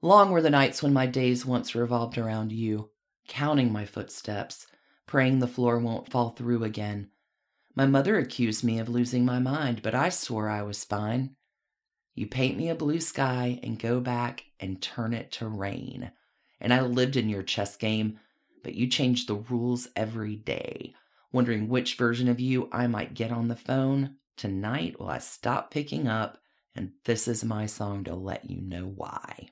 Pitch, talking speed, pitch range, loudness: 120 Hz, 185 wpm, 110-130 Hz, -28 LUFS